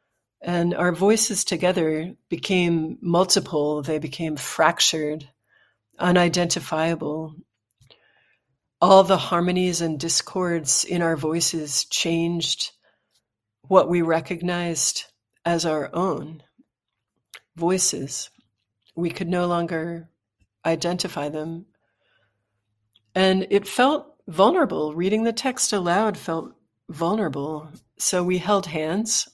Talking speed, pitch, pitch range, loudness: 95 wpm, 170 Hz, 155-185 Hz, -22 LUFS